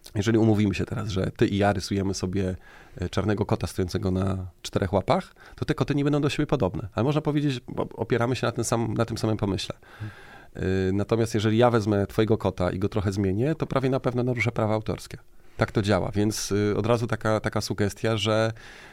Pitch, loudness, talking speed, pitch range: 110 Hz, -26 LUFS, 200 wpm, 100-120 Hz